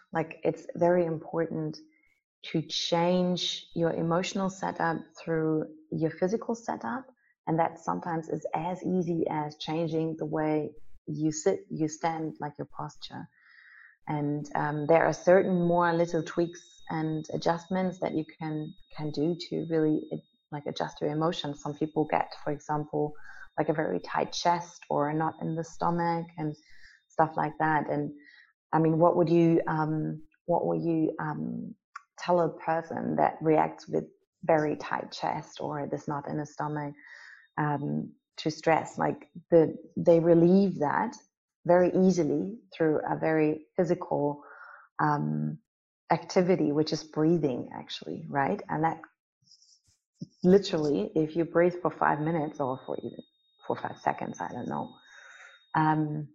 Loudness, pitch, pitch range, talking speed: -29 LUFS, 160 Hz, 155-175 Hz, 145 wpm